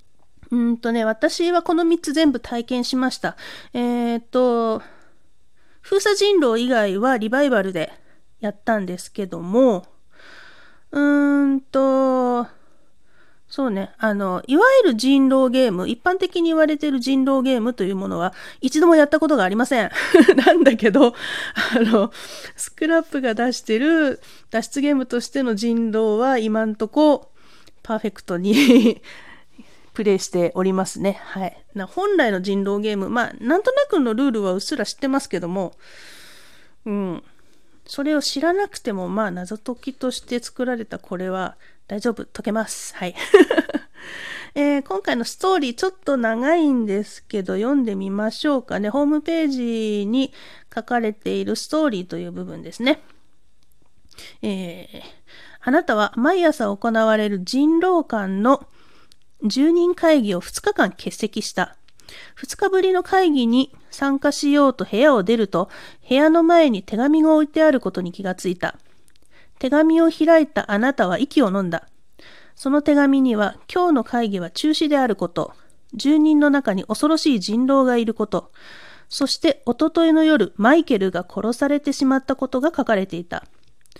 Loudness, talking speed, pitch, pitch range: -19 LUFS, 300 characters per minute, 255 Hz, 215-300 Hz